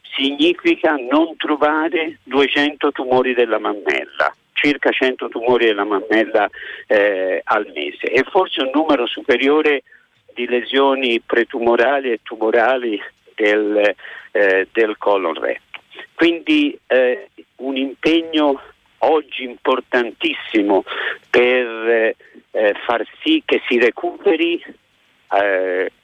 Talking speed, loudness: 100 wpm, -17 LUFS